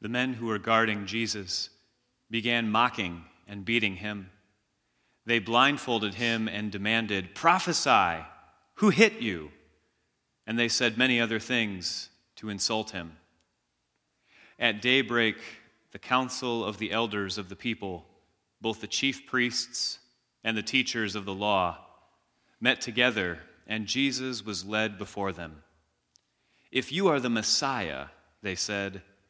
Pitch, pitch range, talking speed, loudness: 110 Hz, 100-120 Hz, 130 wpm, -28 LUFS